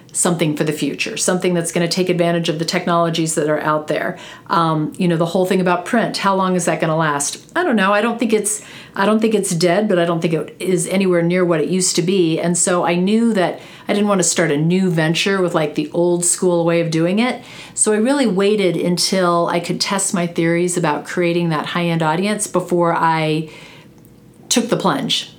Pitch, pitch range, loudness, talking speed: 175 Hz, 165-190 Hz, -17 LUFS, 235 wpm